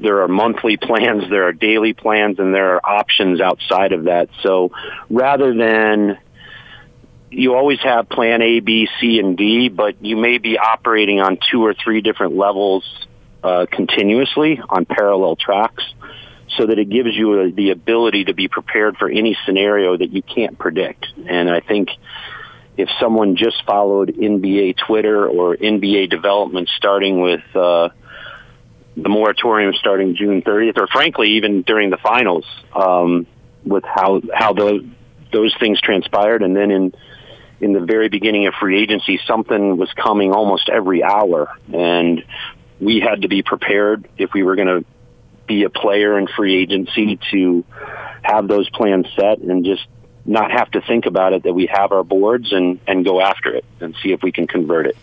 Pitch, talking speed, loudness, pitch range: 100 Hz, 170 wpm, -15 LUFS, 95-110 Hz